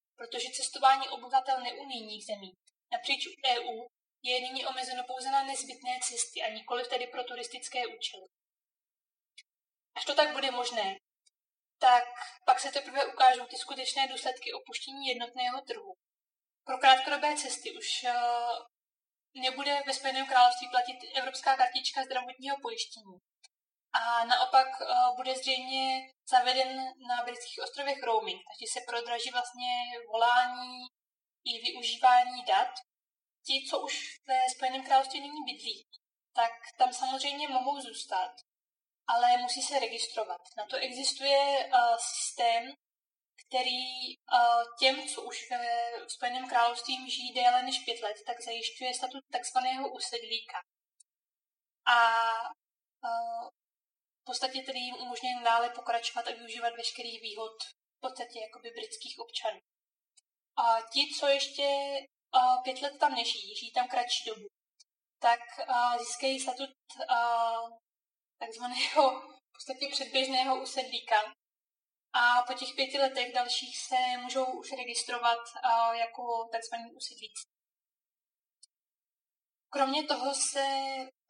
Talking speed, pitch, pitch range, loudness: 120 wpm, 255 Hz, 240-270 Hz, -31 LUFS